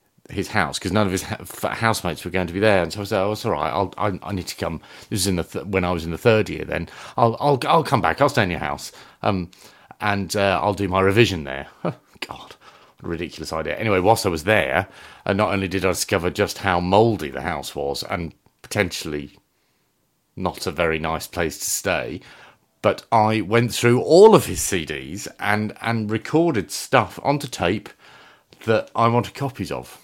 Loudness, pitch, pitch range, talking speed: -21 LUFS, 100 Hz, 90-110 Hz, 210 wpm